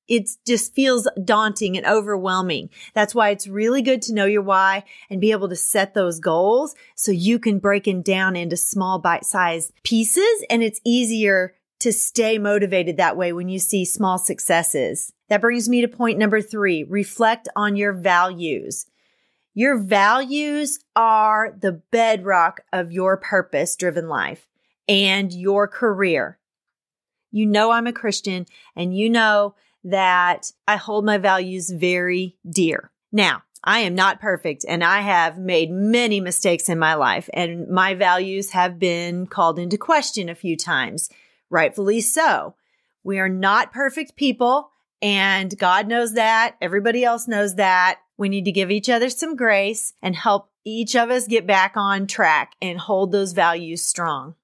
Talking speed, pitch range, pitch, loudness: 165 wpm, 185-225 Hz, 200 Hz, -19 LUFS